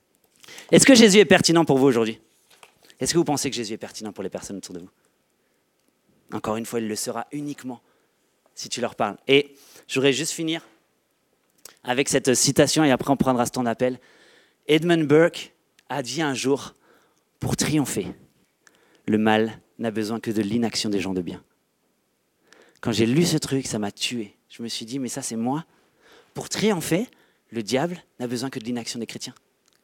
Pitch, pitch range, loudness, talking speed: 125 Hz, 115-145 Hz, -22 LUFS, 185 wpm